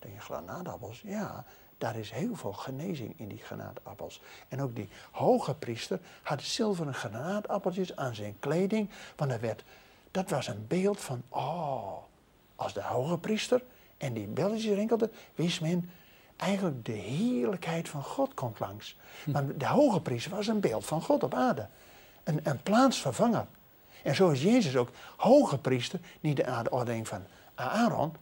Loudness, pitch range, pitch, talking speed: -31 LUFS, 125-200 Hz, 155 Hz, 155 wpm